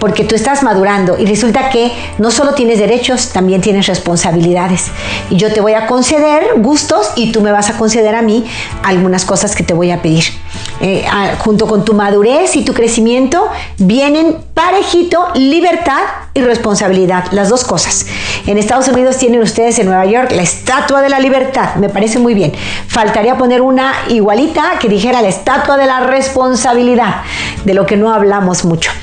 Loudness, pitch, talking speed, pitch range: -10 LUFS, 225 Hz, 180 wpm, 200-260 Hz